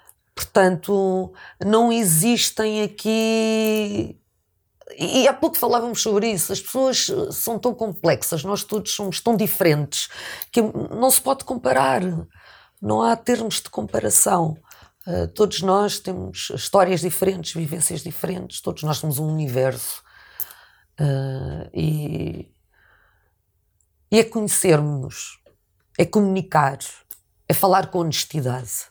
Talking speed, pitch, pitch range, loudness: 110 wpm, 190 Hz, 155-220 Hz, -21 LUFS